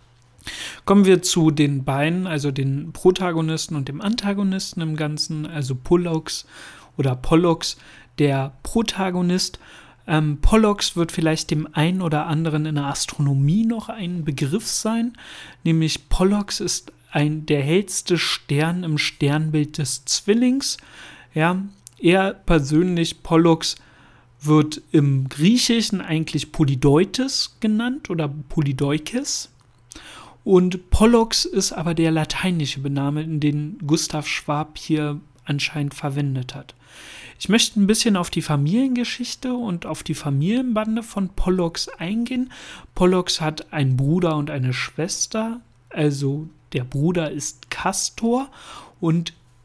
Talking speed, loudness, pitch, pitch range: 120 wpm, -21 LUFS, 160 Hz, 150-190 Hz